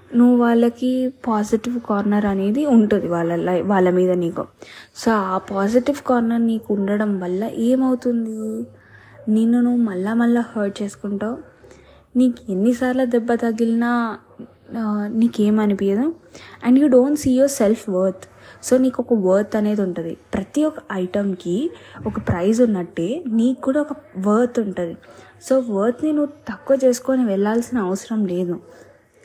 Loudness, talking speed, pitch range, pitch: -19 LUFS, 125 wpm, 200-250 Hz, 225 Hz